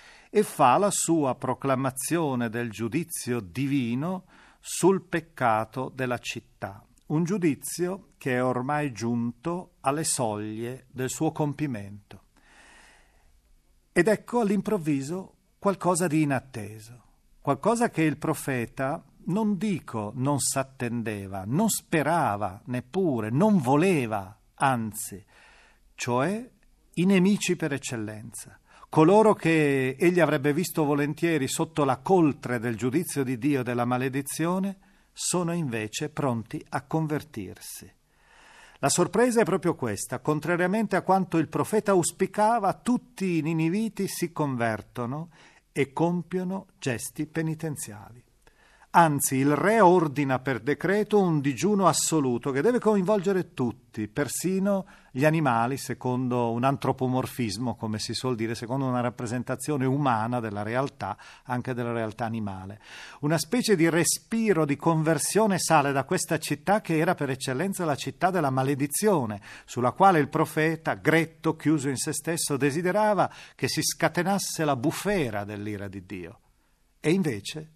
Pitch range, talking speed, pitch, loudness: 125-175 Hz, 125 wpm, 145 Hz, -26 LUFS